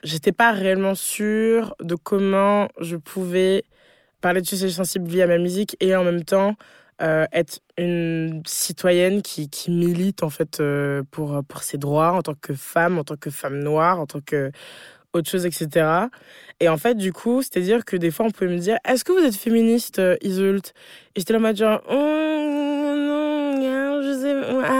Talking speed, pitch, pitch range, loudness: 185 wpm, 185 Hz, 165-225 Hz, -21 LUFS